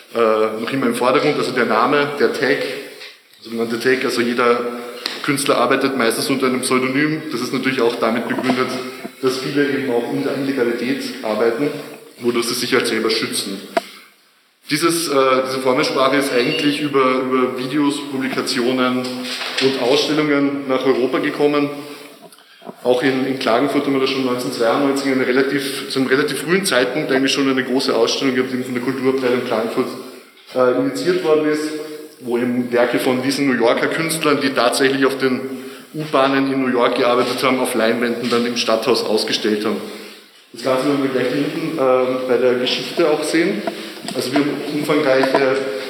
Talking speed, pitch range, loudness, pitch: 165 wpm, 125-140 Hz, -18 LUFS, 130 Hz